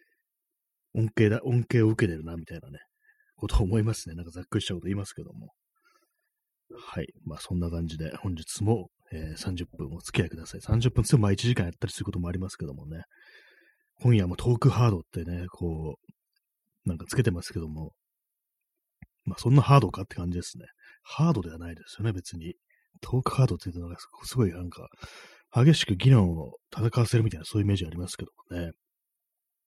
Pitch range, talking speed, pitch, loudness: 85-125 Hz, 395 characters per minute, 105 Hz, -27 LUFS